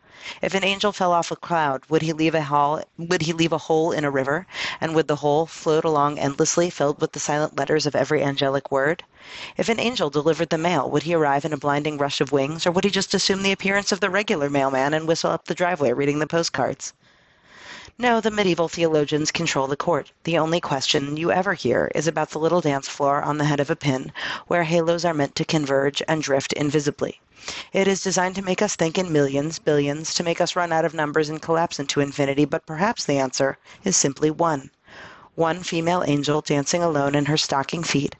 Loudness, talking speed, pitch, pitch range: -22 LUFS, 220 wpm, 160 Hz, 145-170 Hz